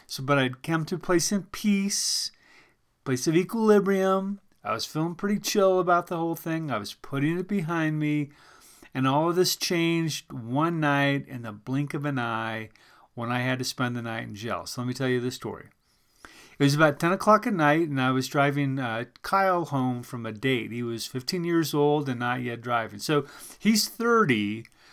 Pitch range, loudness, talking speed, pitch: 125-175 Hz, -26 LUFS, 205 wpm, 145 Hz